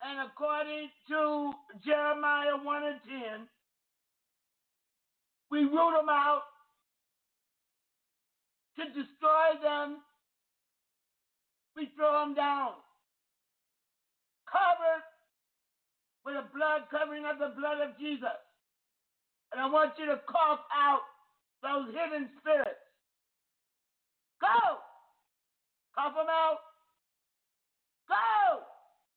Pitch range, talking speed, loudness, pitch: 285-310 Hz, 90 wpm, -31 LUFS, 295 Hz